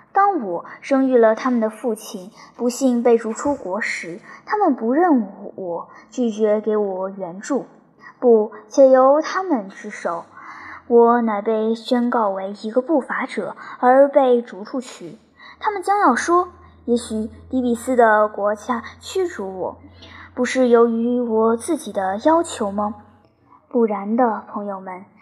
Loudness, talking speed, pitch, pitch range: -19 LUFS, 200 characters per minute, 235 Hz, 210-265 Hz